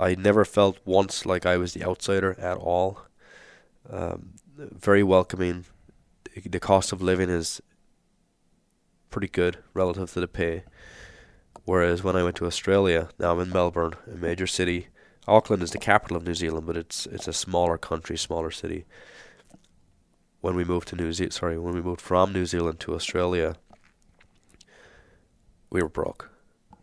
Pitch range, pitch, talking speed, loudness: 85-95 Hz, 90 Hz, 160 wpm, -26 LUFS